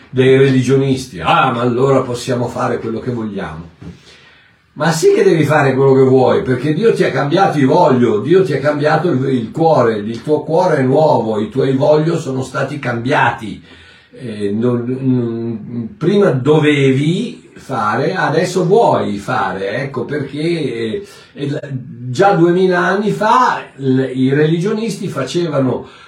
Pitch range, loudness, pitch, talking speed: 125-160 Hz, -14 LUFS, 135 Hz, 130 wpm